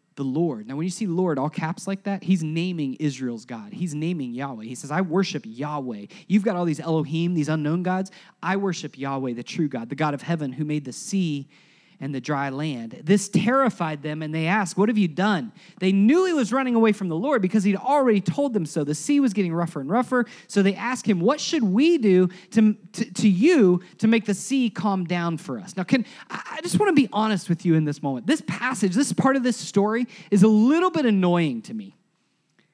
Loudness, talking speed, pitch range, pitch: -23 LUFS, 235 wpm, 160-220 Hz, 185 Hz